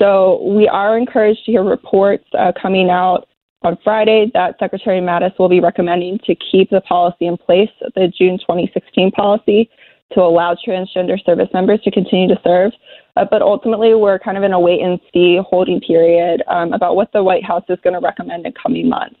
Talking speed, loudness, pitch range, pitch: 195 wpm, -14 LUFS, 180-205 Hz, 190 Hz